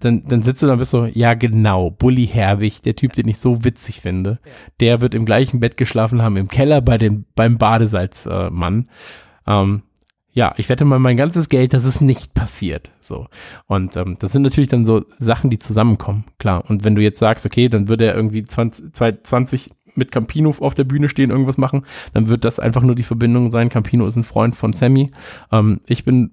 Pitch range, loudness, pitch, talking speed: 110-125 Hz, -16 LUFS, 115 Hz, 210 wpm